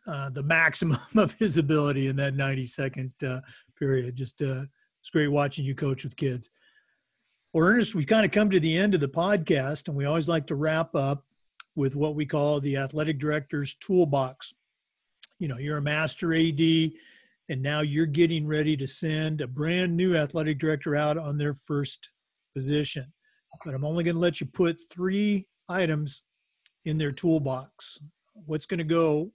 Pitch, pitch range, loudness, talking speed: 155 Hz, 140-165 Hz, -27 LUFS, 180 wpm